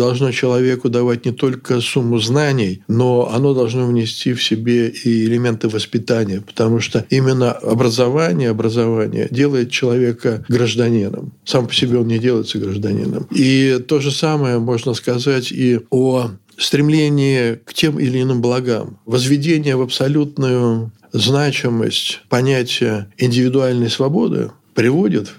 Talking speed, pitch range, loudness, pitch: 125 wpm, 115-130 Hz, -16 LUFS, 125 Hz